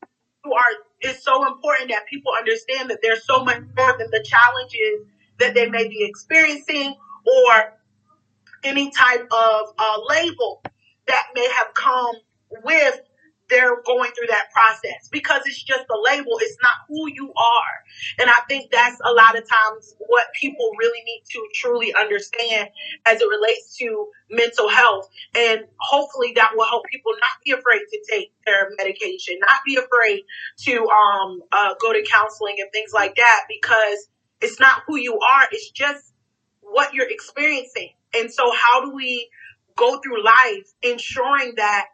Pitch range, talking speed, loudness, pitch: 225-320 Hz, 165 wpm, -18 LUFS, 255 Hz